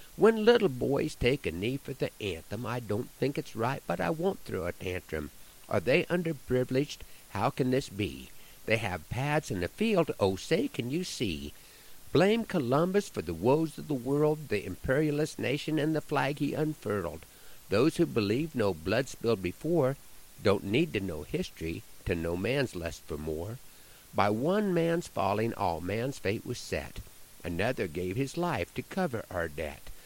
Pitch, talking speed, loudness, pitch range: 130 Hz, 180 wpm, -31 LUFS, 100-155 Hz